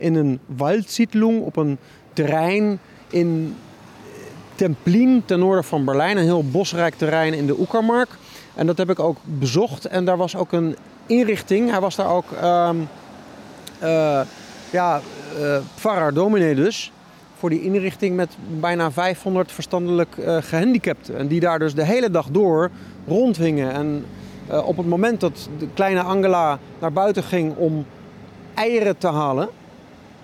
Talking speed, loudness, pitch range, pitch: 150 wpm, -20 LUFS, 155-195 Hz, 175 Hz